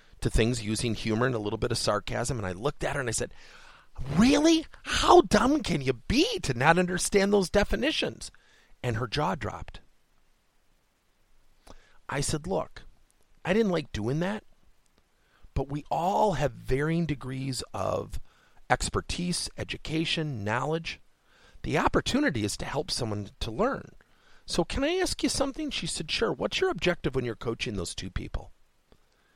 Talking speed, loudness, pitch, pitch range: 155 wpm, -28 LUFS, 145 Hz, 115-185 Hz